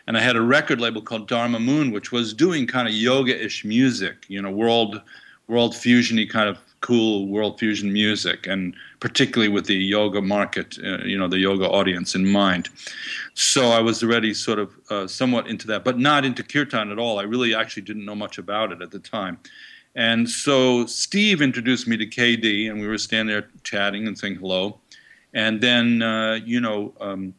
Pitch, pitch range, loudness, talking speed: 110 Hz, 100-120 Hz, -21 LUFS, 200 wpm